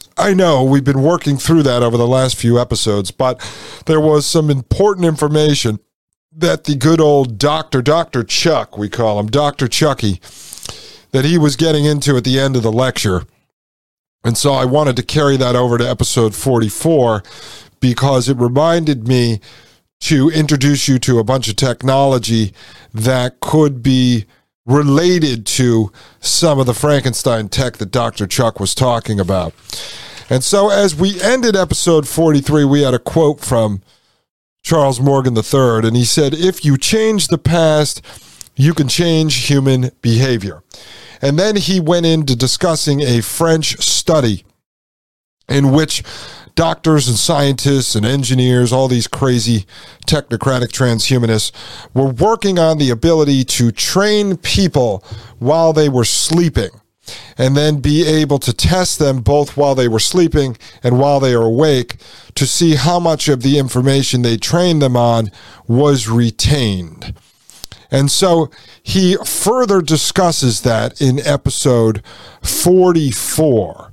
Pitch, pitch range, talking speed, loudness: 135 Hz, 120-155 Hz, 145 wpm, -13 LUFS